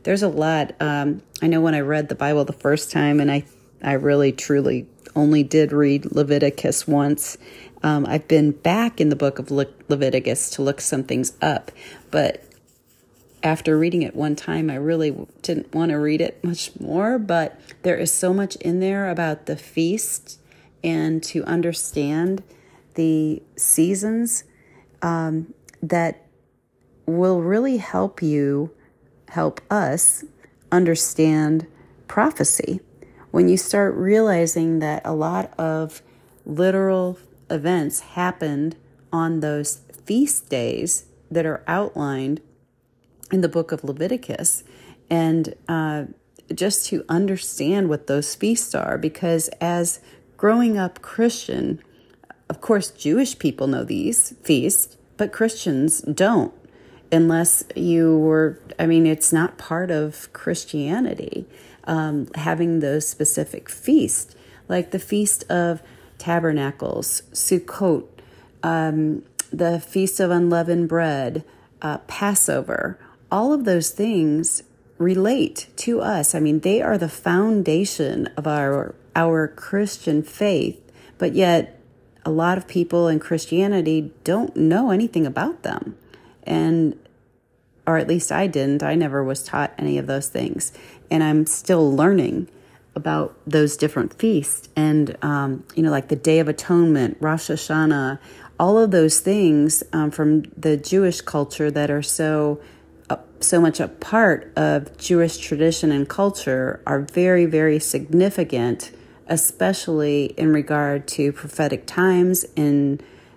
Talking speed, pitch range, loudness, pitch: 135 wpm, 145-175 Hz, -21 LUFS, 160 Hz